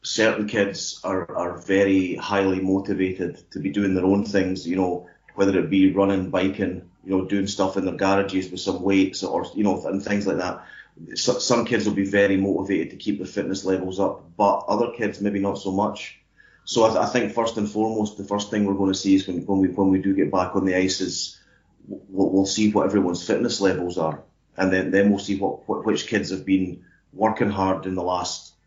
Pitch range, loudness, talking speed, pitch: 95-100 Hz, -23 LUFS, 225 wpm, 95 Hz